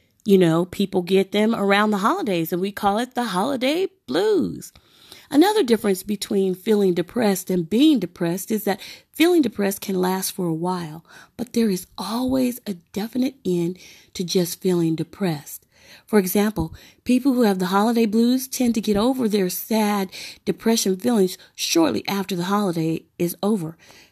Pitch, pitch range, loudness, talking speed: 200 Hz, 185-230 Hz, -21 LUFS, 160 wpm